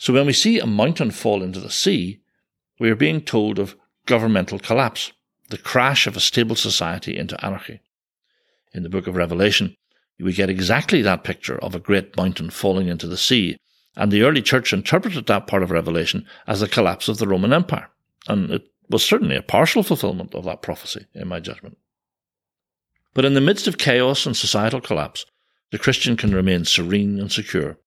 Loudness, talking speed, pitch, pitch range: -19 LUFS, 190 wpm, 100 Hz, 95-120 Hz